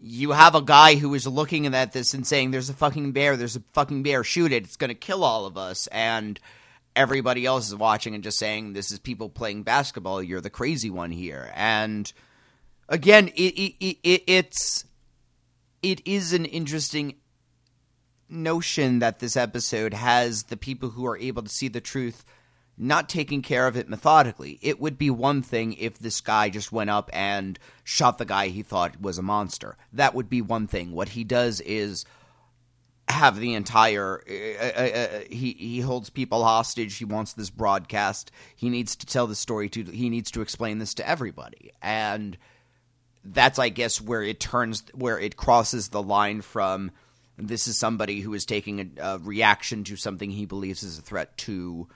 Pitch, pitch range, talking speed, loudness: 115 Hz, 105-130 Hz, 190 wpm, -24 LUFS